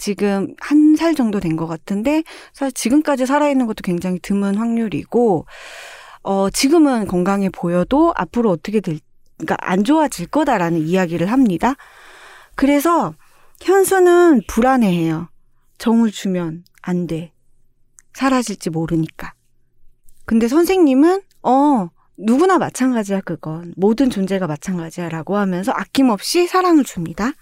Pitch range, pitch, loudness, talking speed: 175-275 Hz, 205 Hz, -17 LUFS, 295 characters per minute